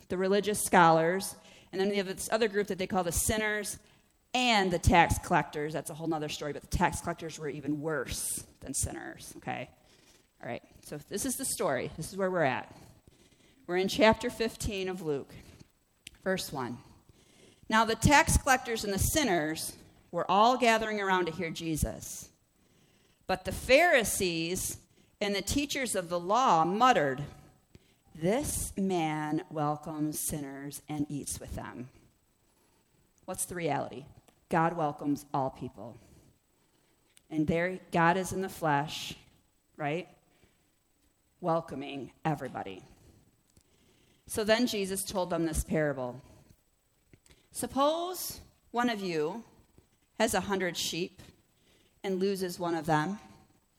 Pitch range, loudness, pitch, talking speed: 150-200 Hz, -30 LUFS, 175 Hz, 135 wpm